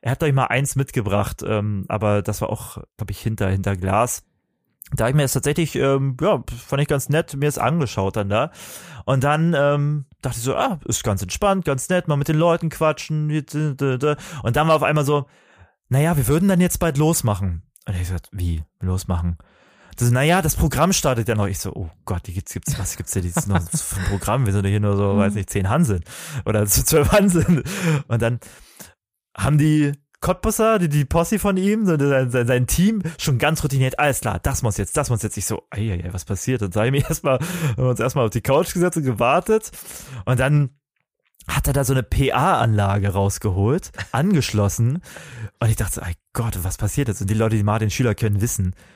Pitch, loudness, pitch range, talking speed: 130 Hz, -20 LUFS, 105-150 Hz, 220 wpm